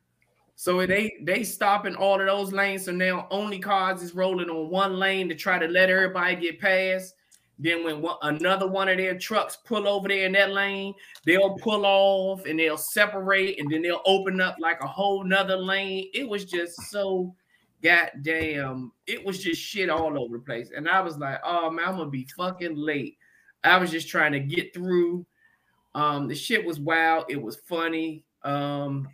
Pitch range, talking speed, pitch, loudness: 160-195 Hz, 195 wpm, 185 Hz, -25 LUFS